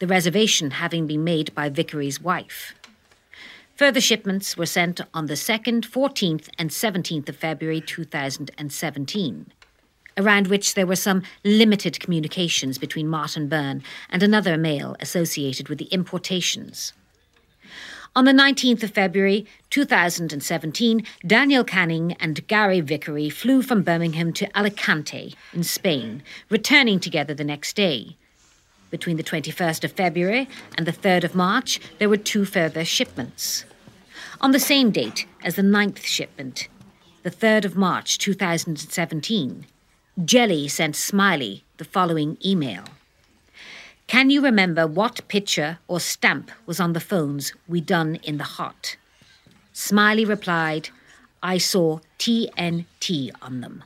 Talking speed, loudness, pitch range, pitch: 130 wpm, -21 LUFS, 160-210 Hz, 175 Hz